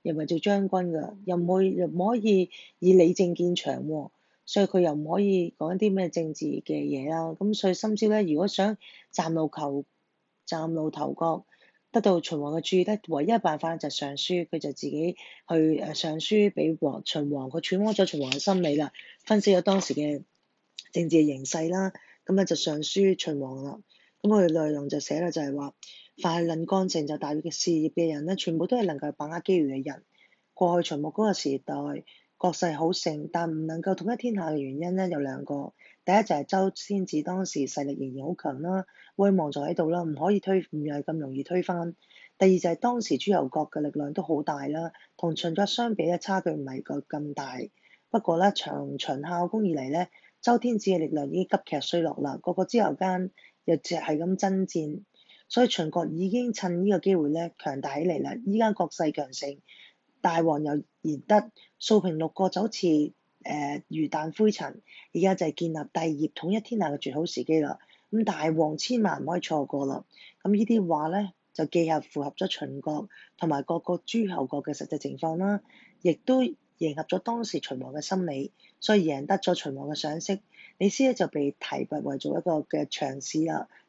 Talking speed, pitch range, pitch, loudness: 285 characters per minute, 150-190 Hz, 170 Hz, -28 LUFS